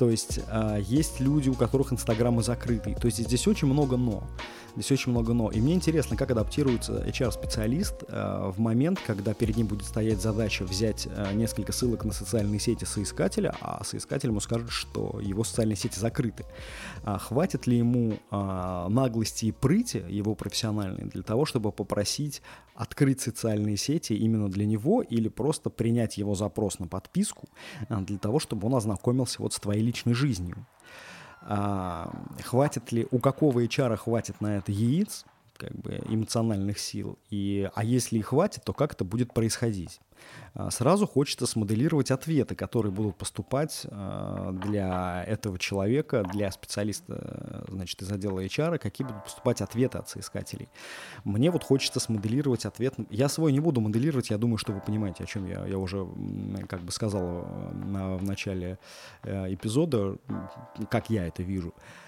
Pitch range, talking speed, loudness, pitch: 100-125 Hz, 155 wpm, -29 LUFS, 110 Hz